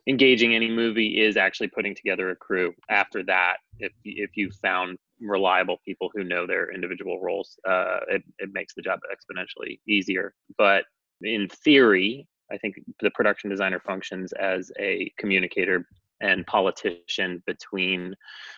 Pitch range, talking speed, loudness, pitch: 90-110 Hz, 145 wpm, -24 LUFS, 100 Hz